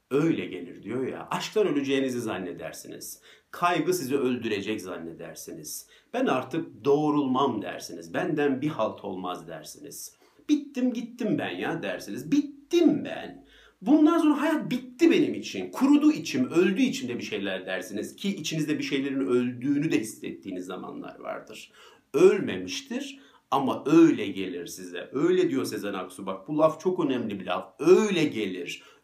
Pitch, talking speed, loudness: 175 Hz, 140 wpm, -26 LUFS